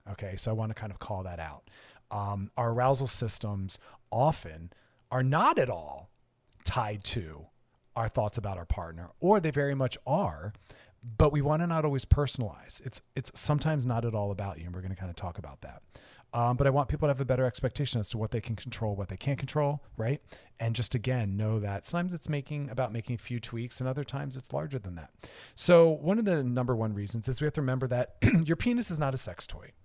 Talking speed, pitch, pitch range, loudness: 235 wpm, 120 Hz, 100-135 Hz, -30 LUFS